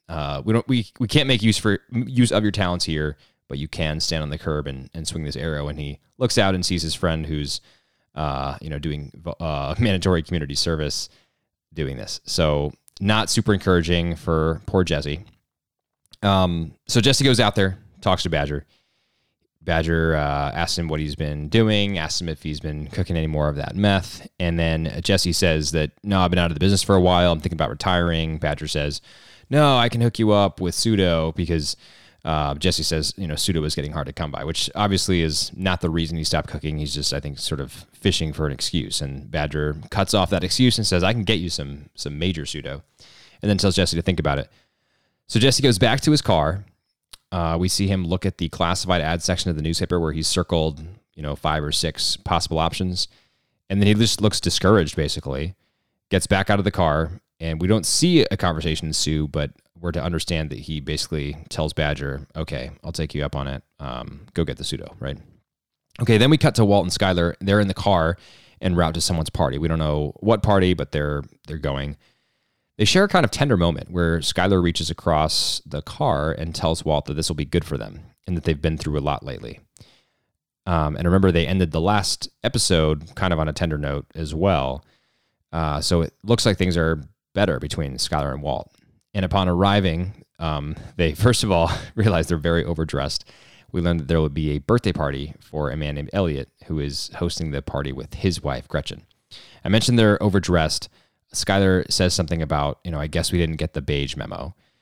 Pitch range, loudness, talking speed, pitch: 75-95 Hz, -22 LUFS, 215 wpm, 85 Hz